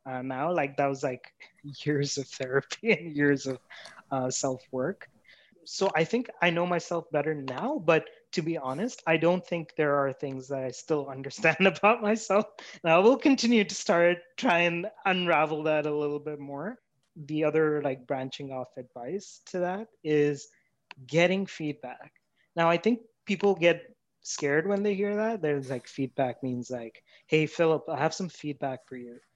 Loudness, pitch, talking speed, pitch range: -28 LUFS, 155 Hz, 180 wpm, 140-185 Hz